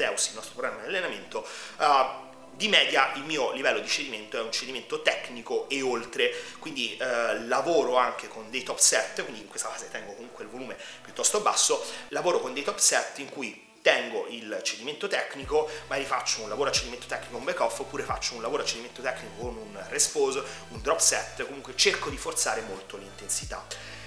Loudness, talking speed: -27 LUFS, 190 wpm